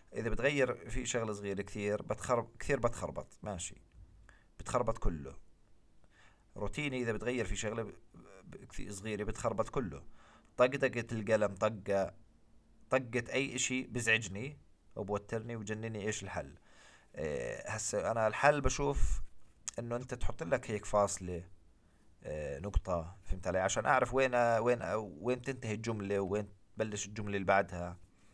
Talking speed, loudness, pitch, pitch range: 140 wpm, -36 LUFS, 105 Hz, 100-120 Hz